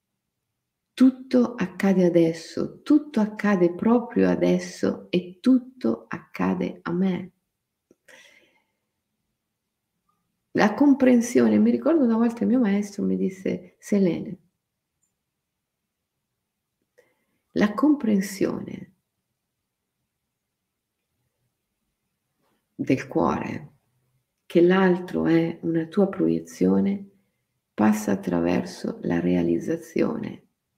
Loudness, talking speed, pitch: -23 LUFS, 75 wpm, 180 Hz